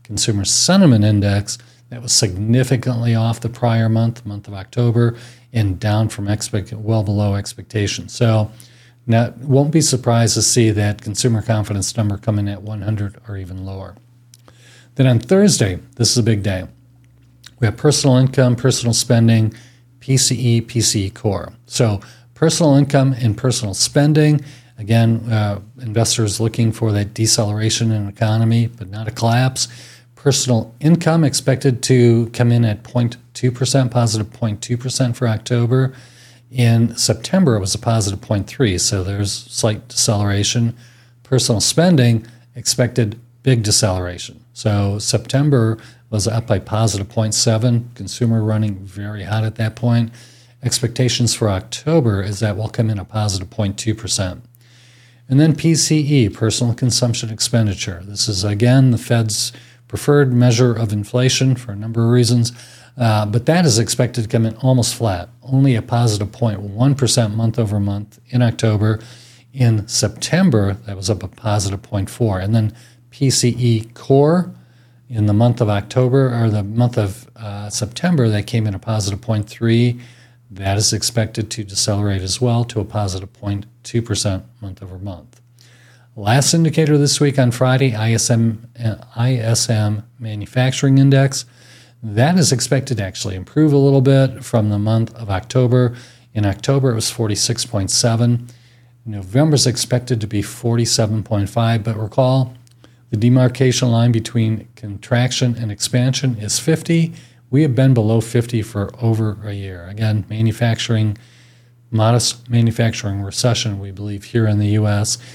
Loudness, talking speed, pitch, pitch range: -17 LUFS, 145 wpm, 115 Hz, 110-125 Hz